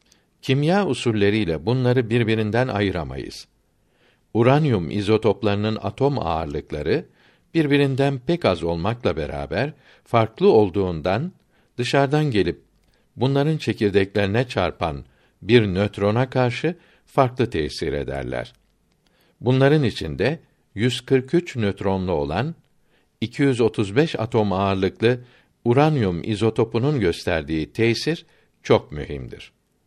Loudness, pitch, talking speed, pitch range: -21 LUFS, 115 Hz, 80 wpm, 100-135 Hz